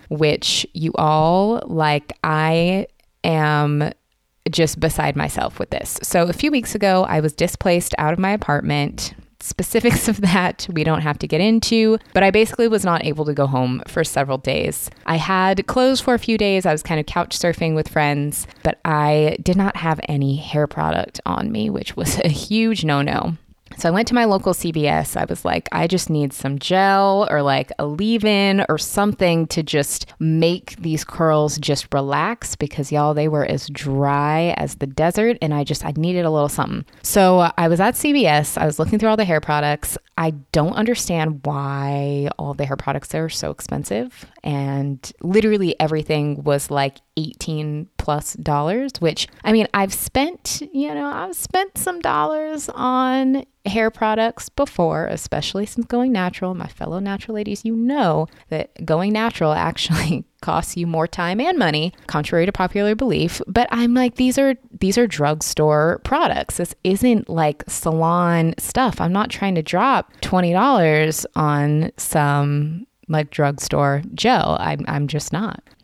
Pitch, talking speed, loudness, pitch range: 165 Hz, 175 wpm, -19 LUFS, 150-205 Hz